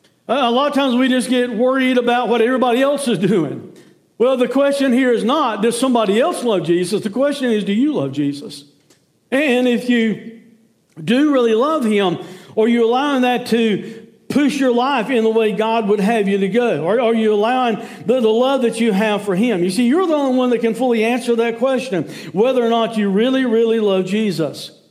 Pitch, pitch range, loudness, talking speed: 230 Hz, 215-255 Hz, -16 LUFS, 210 wpm